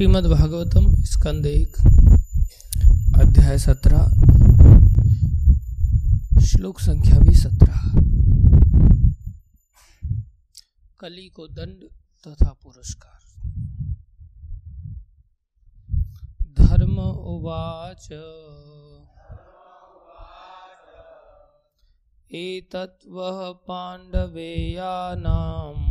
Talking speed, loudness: 45 wpm, -18 LUFS